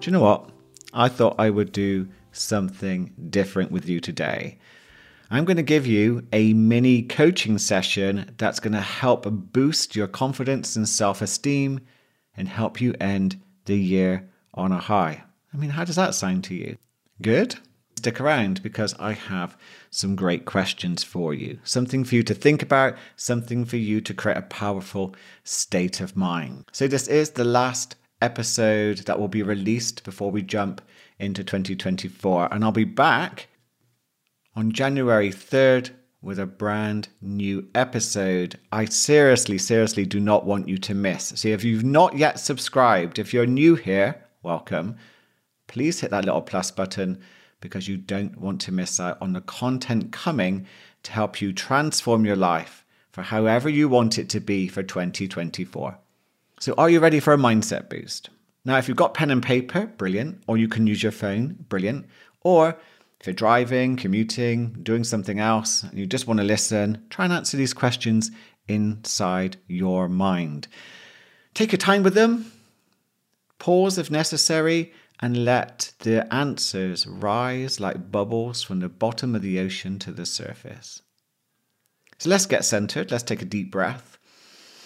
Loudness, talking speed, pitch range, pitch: -23 LUFS, 165 wpm, 95-125 Hz, 110 Hz